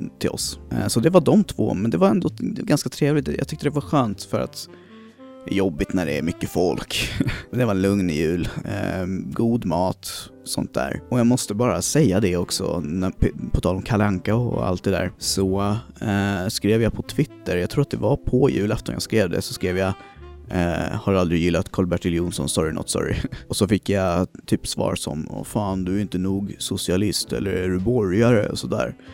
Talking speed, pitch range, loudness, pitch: 205 wpm, 90-125 Hz, -22 LUFS, 100 Hz